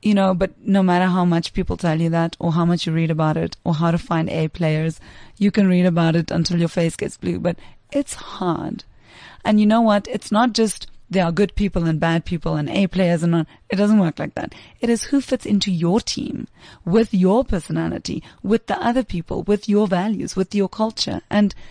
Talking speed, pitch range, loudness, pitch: 225 wpm, 170-210 Hz, -20 LUFS, 185 Hz